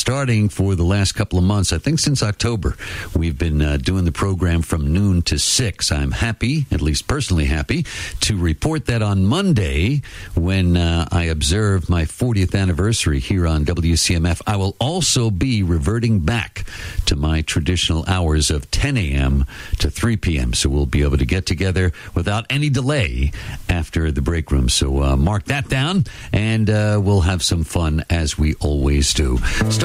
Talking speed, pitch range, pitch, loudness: 175 wpm, 80-110 Hz, 90 Hz, -19 LUFS